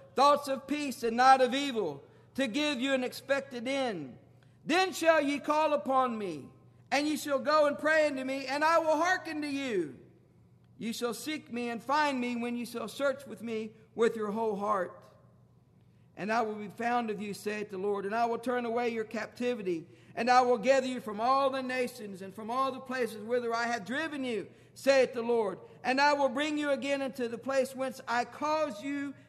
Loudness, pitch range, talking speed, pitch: -31 LUFS, 230-280 Hz, 210 wpm, 255 Hz